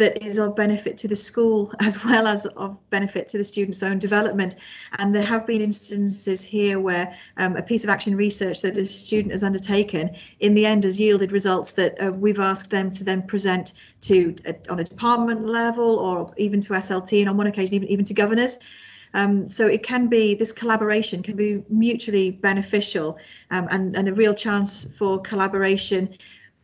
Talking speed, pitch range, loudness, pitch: 195 wpm, 190-215 Hz, -22 LUFS, 200 Hz